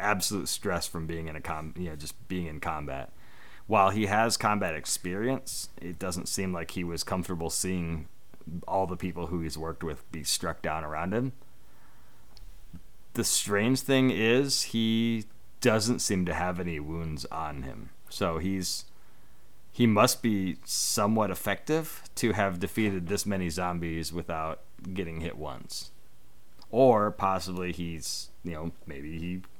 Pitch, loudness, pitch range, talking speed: 90 Hz, -30 LUFS, 85-105 Hz, 150 wpm